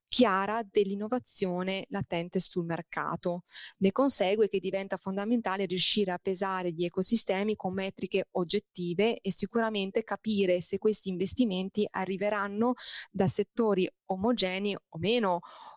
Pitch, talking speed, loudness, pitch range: 195 Hz, 115 wpm, -30 LUFS, 185-215 Hz